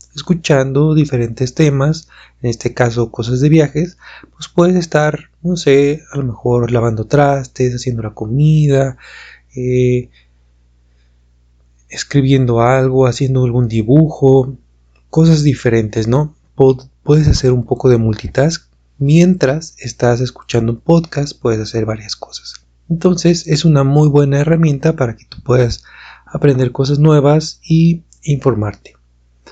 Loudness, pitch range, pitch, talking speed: -13 LUFS, 120-150 Hz, 130 Hz, 125 wpm